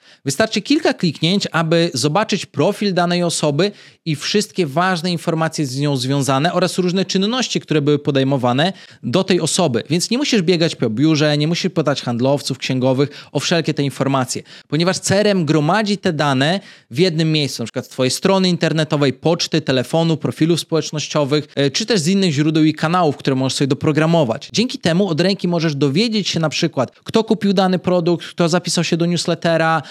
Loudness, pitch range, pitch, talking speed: -17 LUFS, 145-185 Hz, 165 Hz, 175 wpm